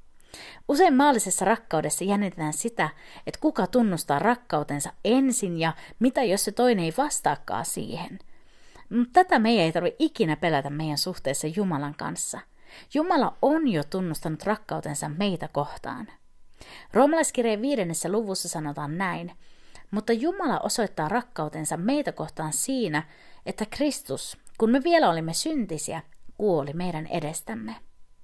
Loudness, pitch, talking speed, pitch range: -26 LUFS, 200 Hz, 125 wpm, 160-245 Hz